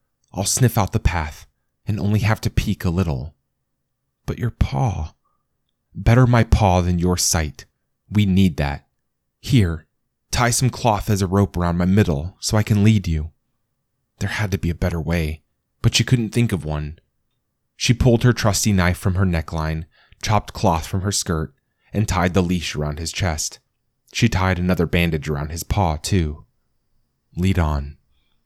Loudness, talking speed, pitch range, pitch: -20 LUFS, 175 wpm, 80-105 Hz, 95 Hz